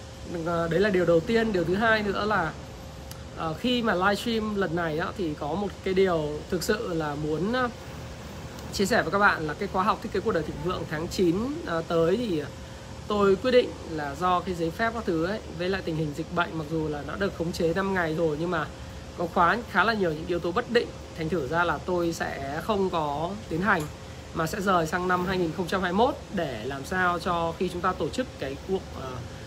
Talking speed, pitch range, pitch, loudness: 225 wpm, 165-195 Hz, 175 Hz, -27 LUFS